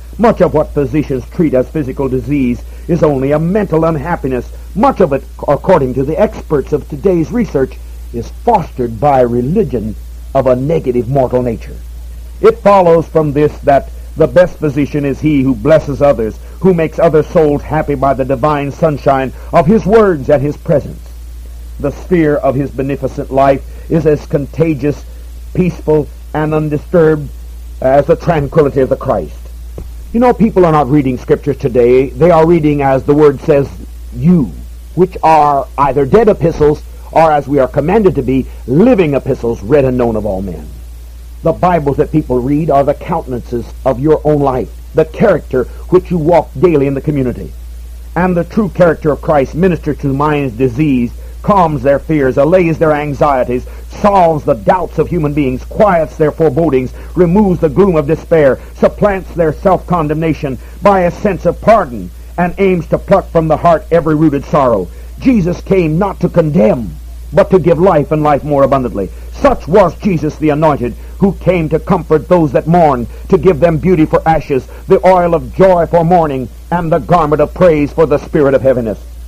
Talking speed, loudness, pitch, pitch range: 175 wpm, -12 LUFS, 150 Hz, 130-170 Hz